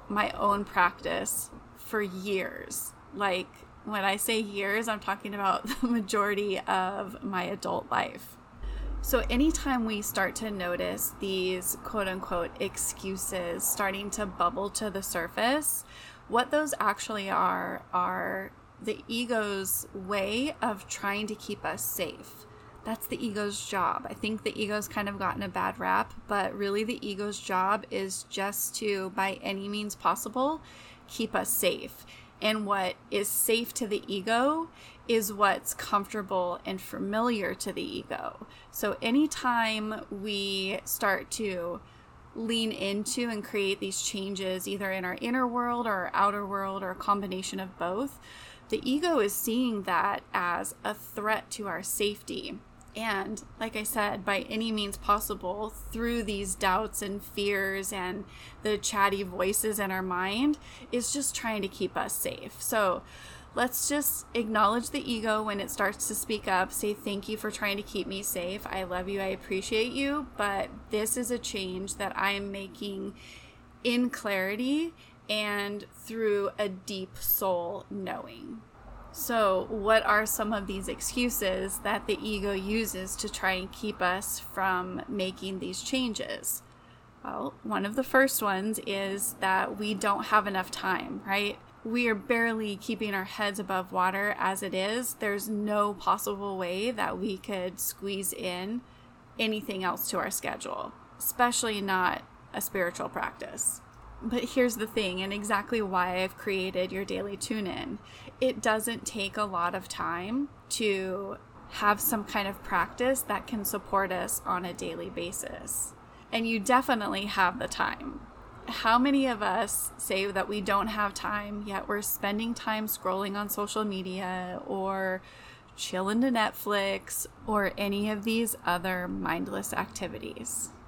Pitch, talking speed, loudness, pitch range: 205 Hz, 155 wpm, -30 LUFS, 195-225 Hz